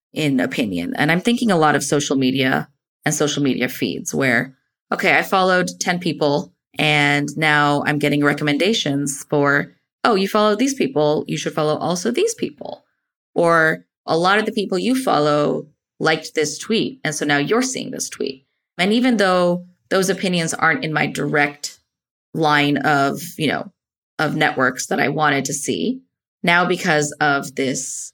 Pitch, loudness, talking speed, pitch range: 150 Hz, -19 LUFS, 170 wpm, 145-185 Hz